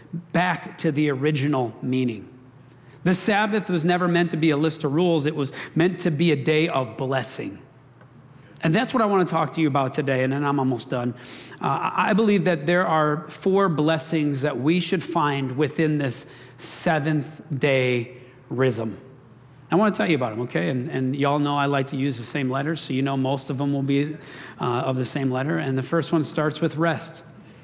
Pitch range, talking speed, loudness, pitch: 130-165 Hz, 210 wpm, -23 LUFS, 145 Hz